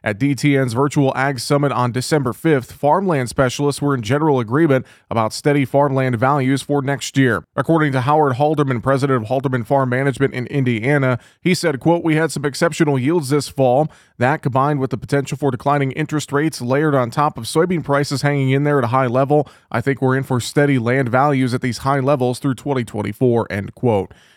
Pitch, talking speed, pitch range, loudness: 140 Hz, 195 wpm, 130-145 Hz, -18 LUFS